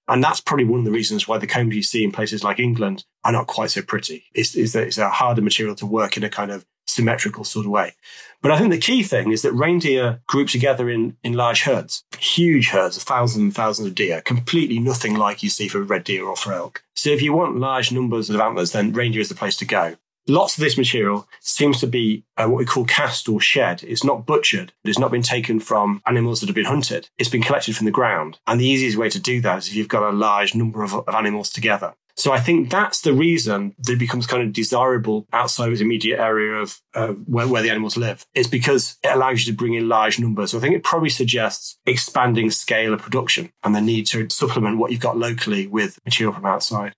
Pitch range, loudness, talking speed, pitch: 105-125 Hz, -19 LUFS, 250 wpm, 115 Hz